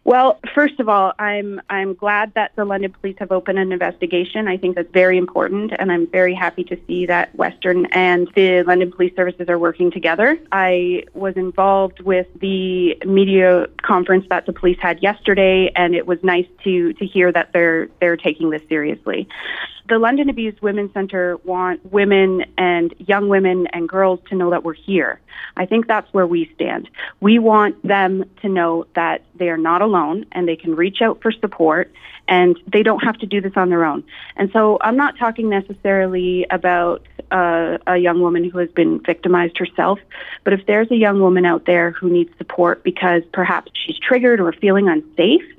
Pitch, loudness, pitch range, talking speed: 185 Hz, -17 LUFS, 175-200 Hz, 190 wpm